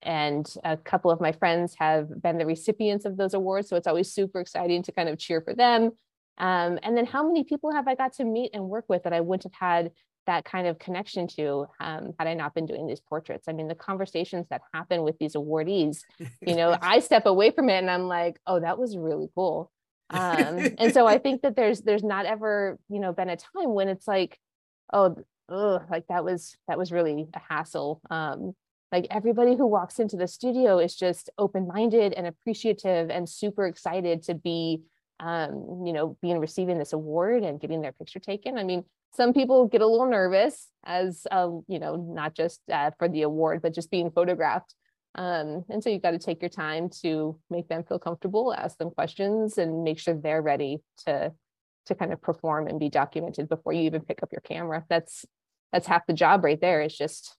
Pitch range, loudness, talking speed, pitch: 165-200 Hz, -27 LUFS, 215 wpm, 175 Hz